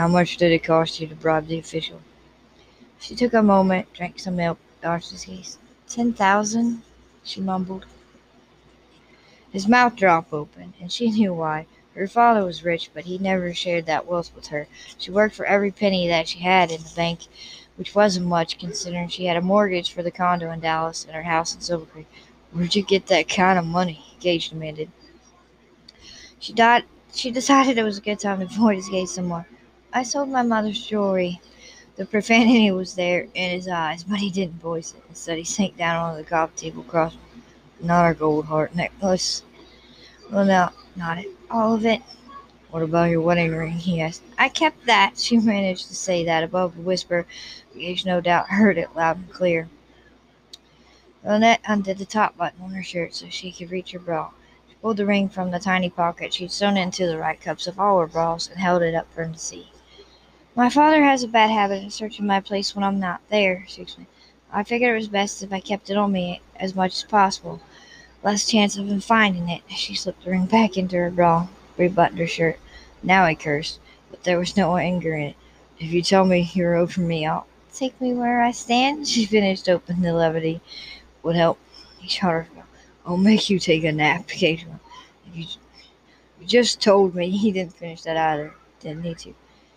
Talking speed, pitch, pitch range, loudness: 205 wpm, 180 Hz, 170-205 Hz, -21 LUFS